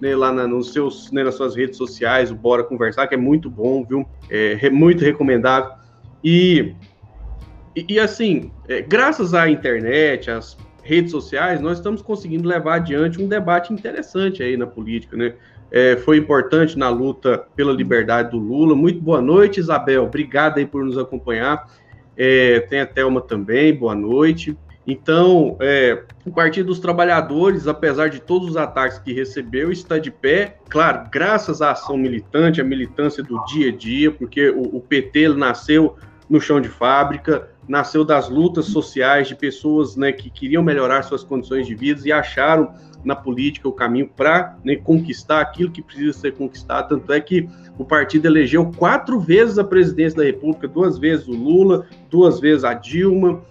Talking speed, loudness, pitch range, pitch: 175 wpm, -17 LUFS, 130-160 Hz, 145 Hz